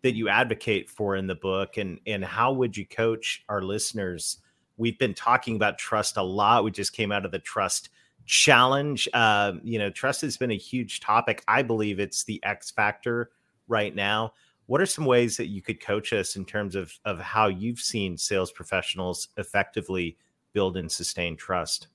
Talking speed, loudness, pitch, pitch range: 190 wpm, -26 LUFS, 110 Hz, 100-120 Hz